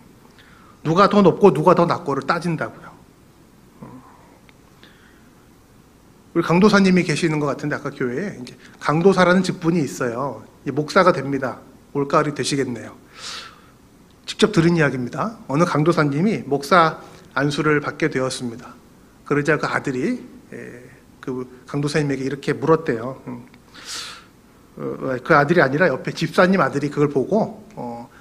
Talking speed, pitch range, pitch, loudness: 280 characters per minute, 135-170 Hz, 150 Hz, -19 LUFS